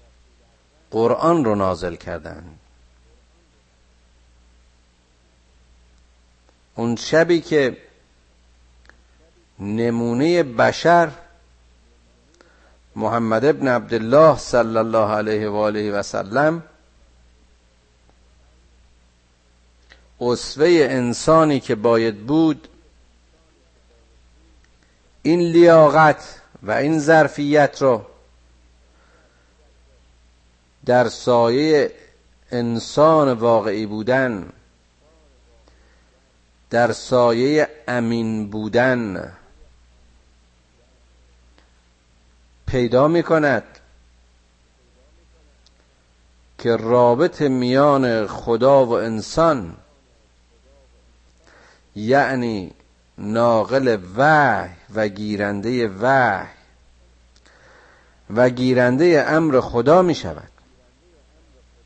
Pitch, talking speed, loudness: 70 Hz, 55 wpm, -18 LUFS